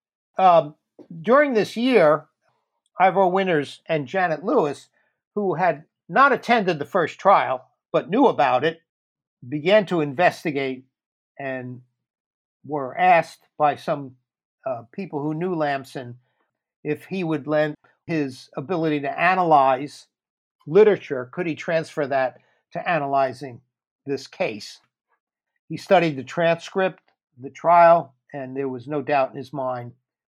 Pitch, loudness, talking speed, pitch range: 150 Hz, -21 LUFS, 125 wpm, 135-180 Hz